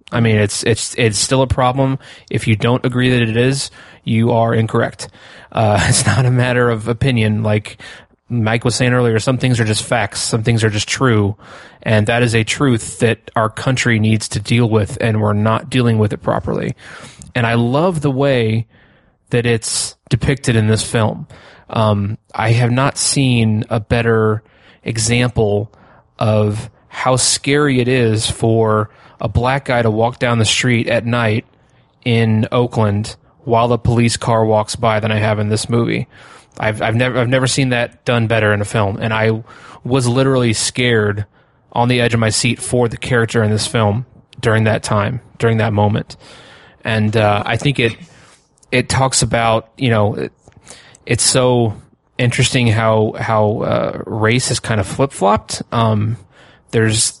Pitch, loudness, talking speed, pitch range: 115 Hz, -15 LUFS, 175 wpm, 110-125 Hz